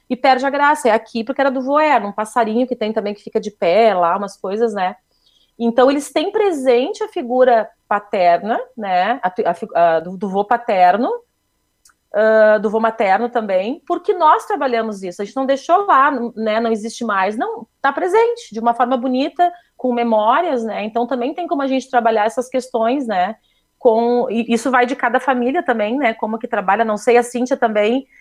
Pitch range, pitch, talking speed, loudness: 220-270 Hz, 240 Hz, 200 wpm, -17 LUFS